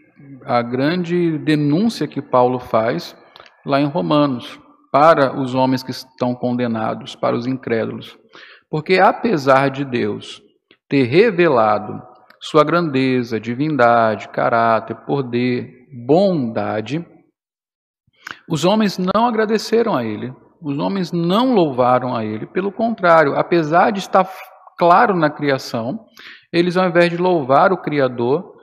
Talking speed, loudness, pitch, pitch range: 120 wpm, -17 LUFS, 145 Hz, 125-180 Hz